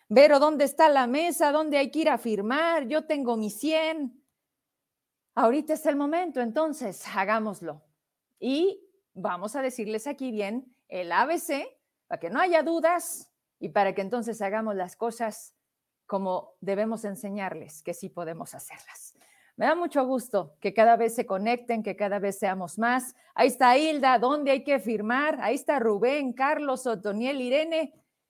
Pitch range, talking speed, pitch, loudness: 205-295 Hz, 160 wpm, 245 Hz, -26 LUFS